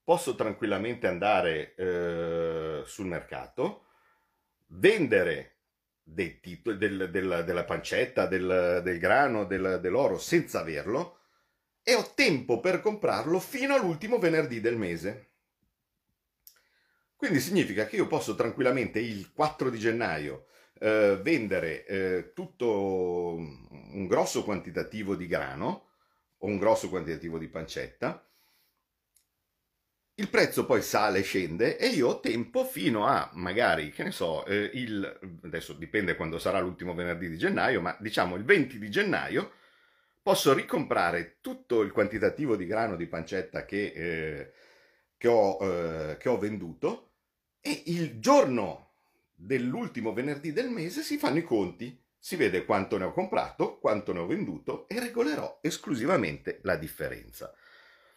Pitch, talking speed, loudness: 115 Hz, 135 wpm, -29 LUFS